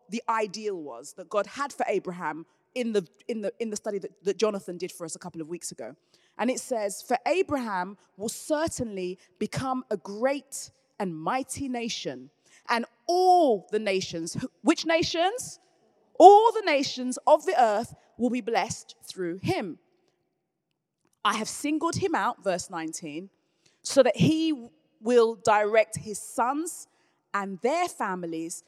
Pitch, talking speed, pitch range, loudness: 215 Hz, 155 wpm, 185-265 Hz, -26 LUFS